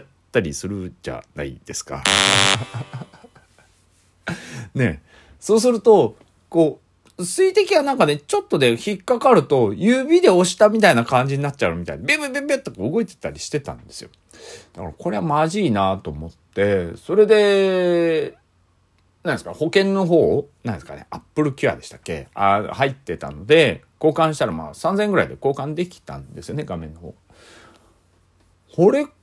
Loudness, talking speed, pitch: -19 LUFS, 320 characters per minute, 150 Hz